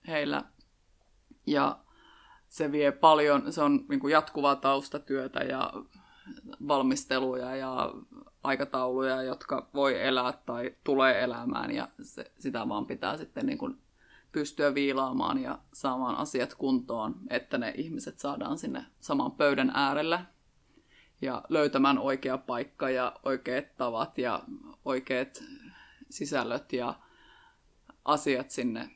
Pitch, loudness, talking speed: 145 Hz, -30 LUFS, 115 wpm